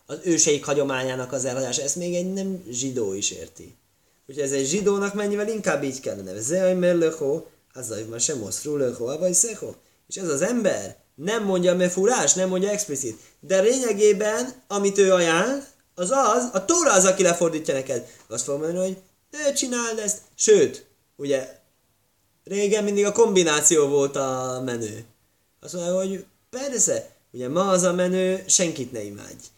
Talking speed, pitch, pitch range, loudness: 165 wpm, 180 Hz, 135-205 Hz, -22 LUFS